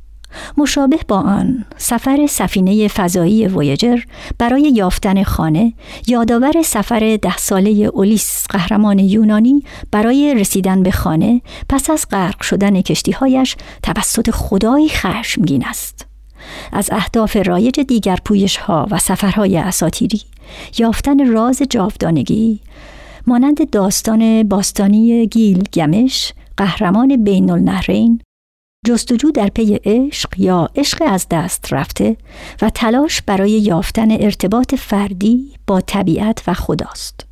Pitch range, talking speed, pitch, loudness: 195-240 Hz, 110 wpm, 215 Hz, -14 LUFS